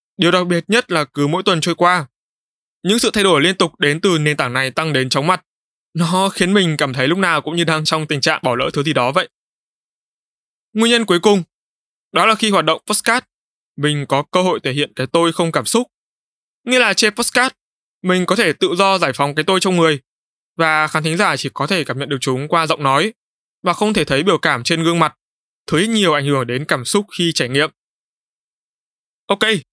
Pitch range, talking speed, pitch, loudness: 150-195 Hz, 230 wpm, 170 Hz, -16 LUFS